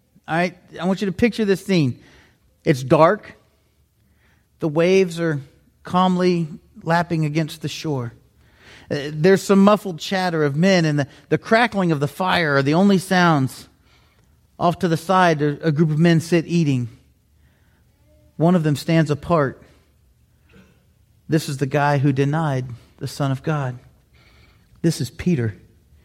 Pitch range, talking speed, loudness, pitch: 140-180 Hz, 145 wpm, -19 LUFS, 160 Hz